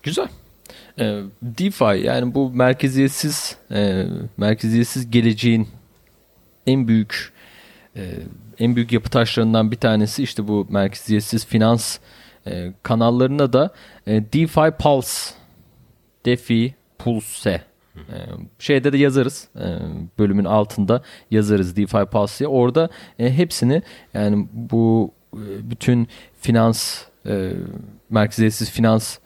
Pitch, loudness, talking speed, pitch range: 115 Hz, -19 LUFS, 85 wpm, 105-130 Hz